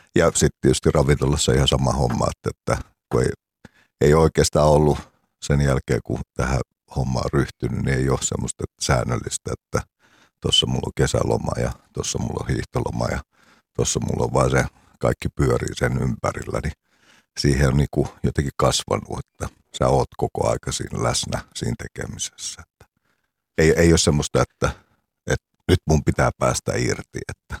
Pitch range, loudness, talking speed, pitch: 65-75 Hz, -22 LUFS, 160 wpm, 70 Hz